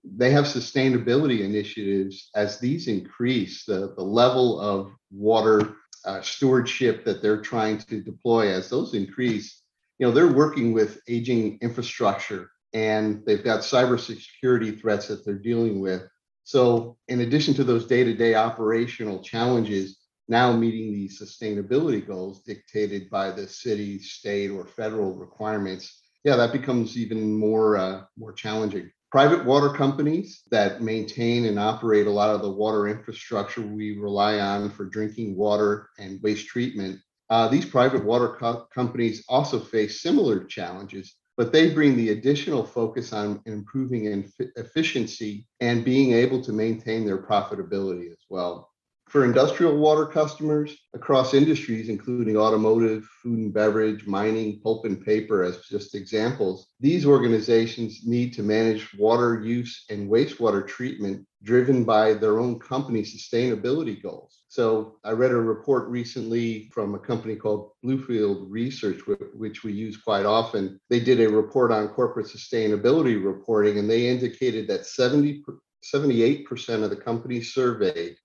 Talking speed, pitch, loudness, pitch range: 145 wpm, 110 Hz, -24 LUFS, 105-125 Hz